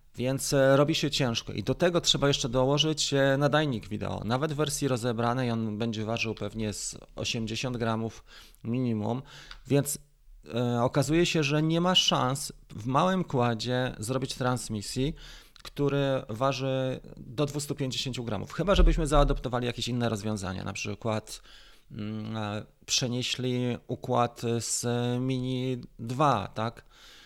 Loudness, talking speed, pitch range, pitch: -28 LUFS, 125 wpm, 115-140 Hz, 125 Hz